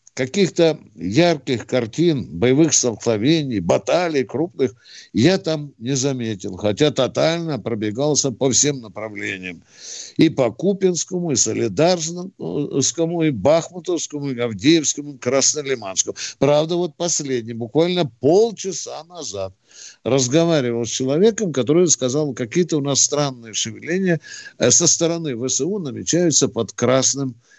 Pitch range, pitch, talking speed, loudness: 120-165 Hz, 140 Hz, 110 wpm, -19 LUFS